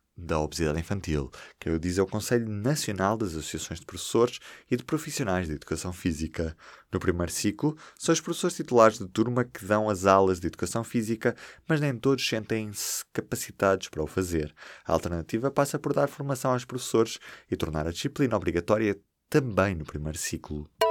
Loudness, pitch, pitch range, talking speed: -28 LUFS, 105 Hz, 85-125 Hz, 175 wpm